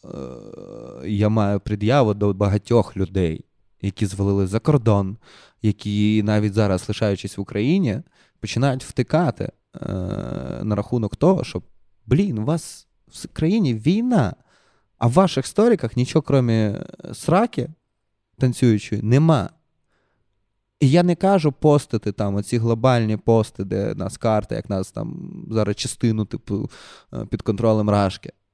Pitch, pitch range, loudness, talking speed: 110 Hz, 105-135 Hz, -21 LUFS, 120 wpm